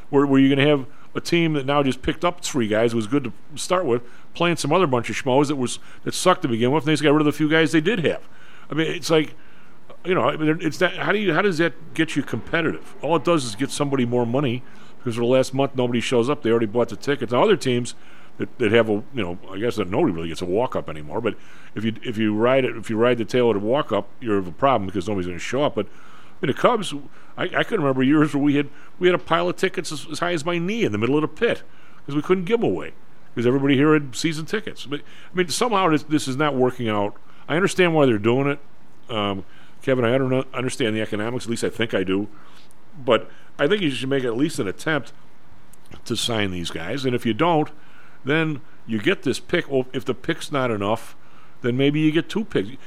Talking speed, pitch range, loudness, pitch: 265 wpm, 120-155 Hz, -22 LUFS, 140 Hz